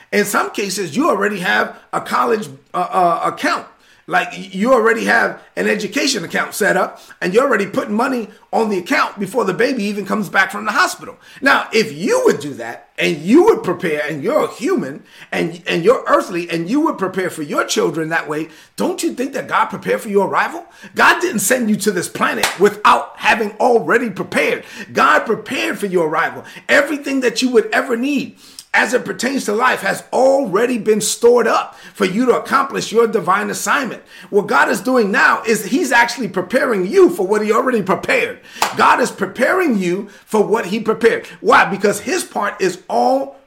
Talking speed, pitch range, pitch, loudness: 195 wpm, 200-260 Hz, 225 Hz, -16 LUFS